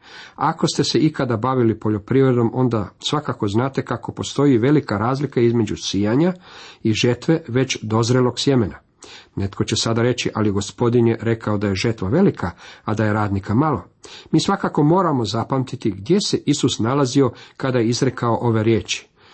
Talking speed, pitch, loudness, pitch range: 155 wpm, 120 Hz, -19 LUFS, 110-135 Hz